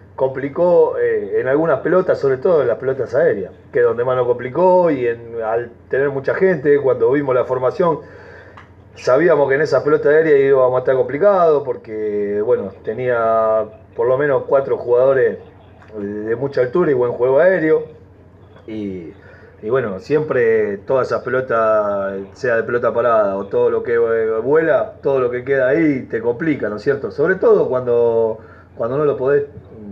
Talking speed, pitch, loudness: 170 wpm, 185 Hz, -17 LUFS